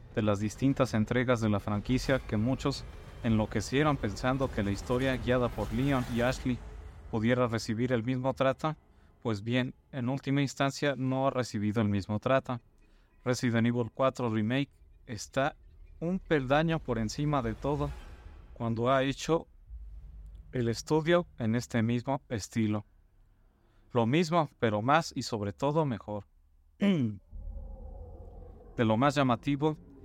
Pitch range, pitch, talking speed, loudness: 105-135 Hz, 120 Hz, 135 wpm, -31 LUFS